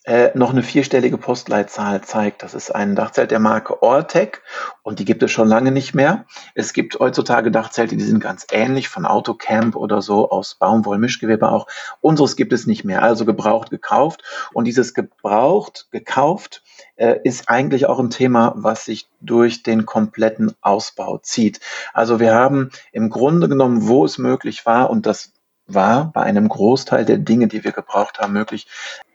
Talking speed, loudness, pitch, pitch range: 175 wpm, -17 LUFS, 115 Hz, 110-125 Hz